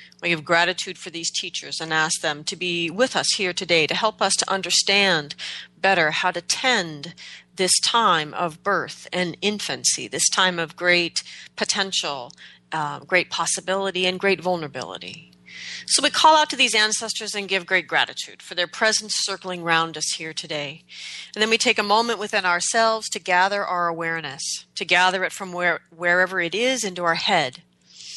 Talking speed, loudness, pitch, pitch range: 175 wpm, -21 LUFS, 180 Hz, 165-200 Hz